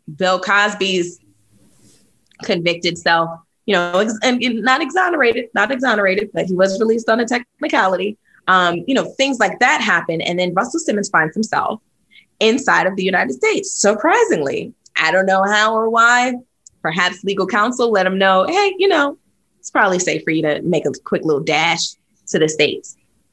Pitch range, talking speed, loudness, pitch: 180-245 Hz, 175 wpm, -16 LUFS, 205 Hz